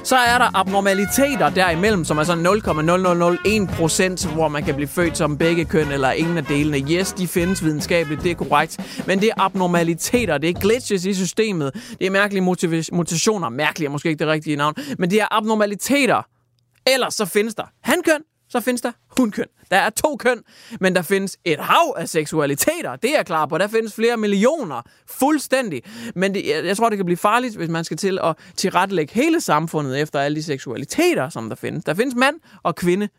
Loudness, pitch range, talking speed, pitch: -19 LUFS, 160-225 Hz, 200 wpm, 185 Hz